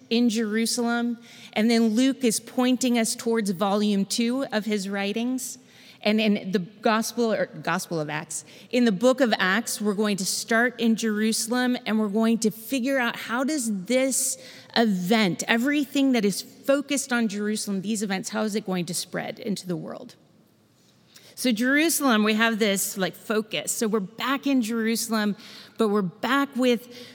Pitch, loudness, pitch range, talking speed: 225 Hz, -24 LUFS, 210-245 Hz, 170 wpm